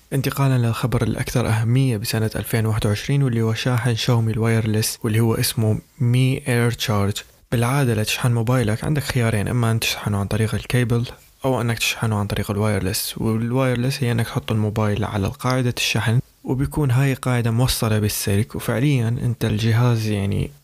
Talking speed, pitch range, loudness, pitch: 150 wpm, 110-125 Hz, -21 LUFS, 115 Hz